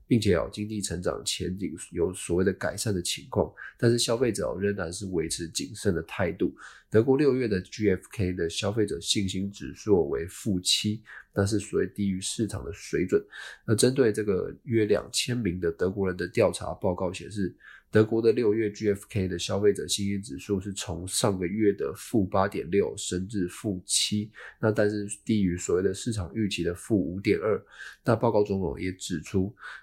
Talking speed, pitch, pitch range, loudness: 280 characters per minute, 100 Hz, 90-105 Hz, -28 LUFS